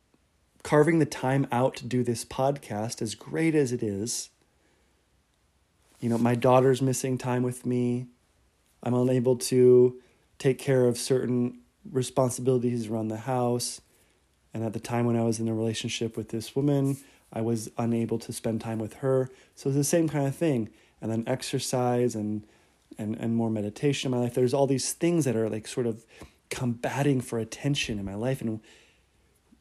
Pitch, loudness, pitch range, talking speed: 125 Hz, -27 LUFS, 115-130 Hz, 175 wpm